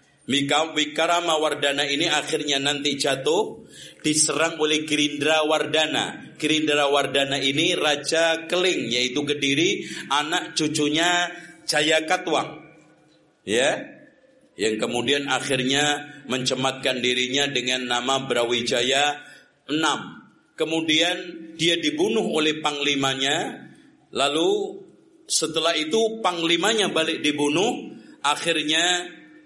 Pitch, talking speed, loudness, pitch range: 155 Hz, 90 wpm, -22 LUFS, 145-170 Hz